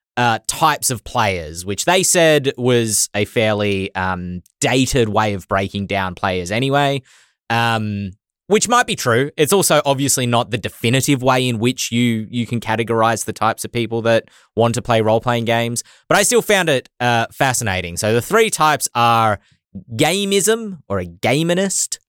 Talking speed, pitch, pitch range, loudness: 170 wpm, 115 Hz, 105-140 Hz, -17 LUFS